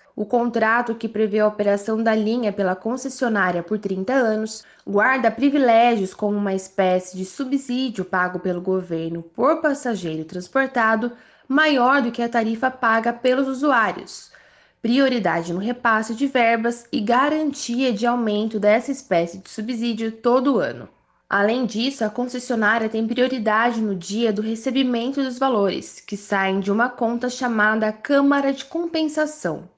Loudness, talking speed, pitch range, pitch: -21 LUFS, 140 wpm, 210-255 Hz, 230 Hz